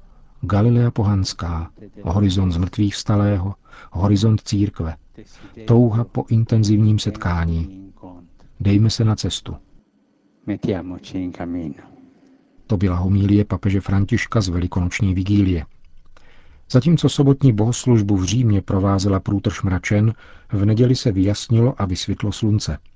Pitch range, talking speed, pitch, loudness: 95-115 Hz, 100 wpm, 100 Hz, -19 LUFS